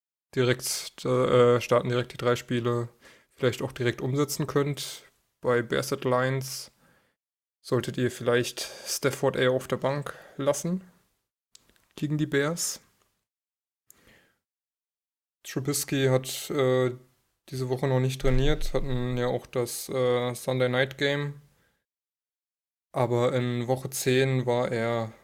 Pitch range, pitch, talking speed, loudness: 120-135 Hz, 130 Hz, 110 wpm, -27 LUFS